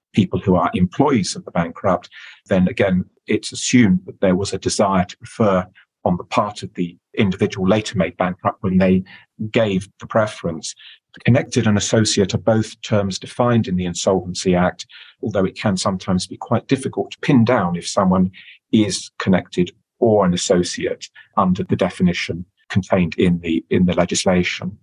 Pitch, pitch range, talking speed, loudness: 95 Hz, 90-110 Hz, 165 wpm, -19 LUFS